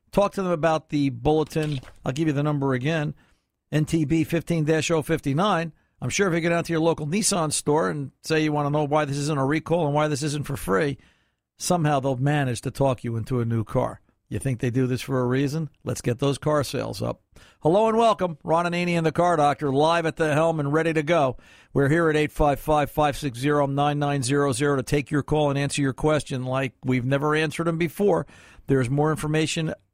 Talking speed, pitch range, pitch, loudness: 215 wpm, 135-160 Hz, 150 Hz, -24 LUFS